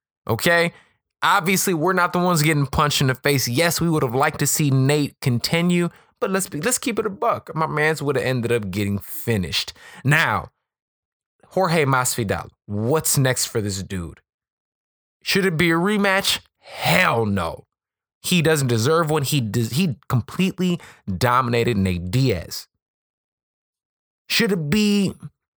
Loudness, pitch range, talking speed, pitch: -20 LUFS, 120-175 Hz, 155 wpm, 150 Hz